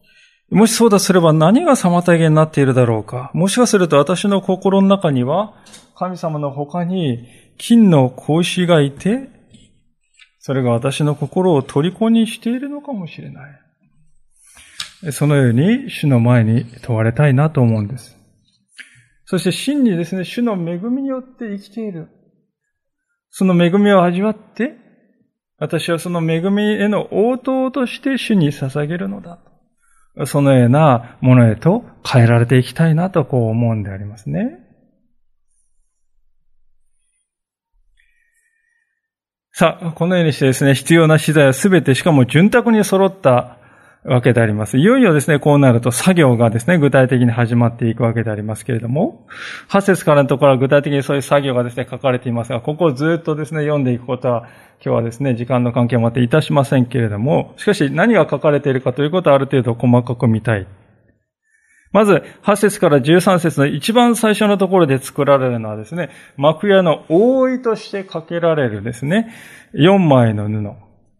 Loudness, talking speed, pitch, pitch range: -15 LUFS, 325 characters per minute, 155 Hz, 130-200 Hz